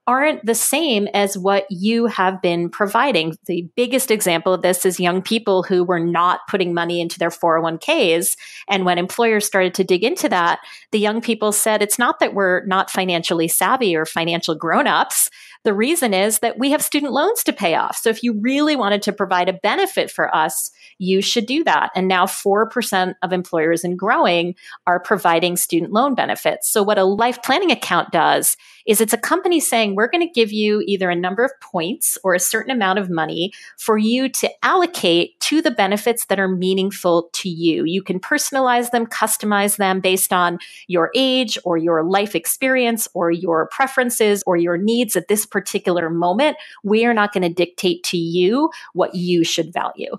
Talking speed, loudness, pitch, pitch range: 190 wpm, -18 LUFS, 200 Hz, 180-235 Hz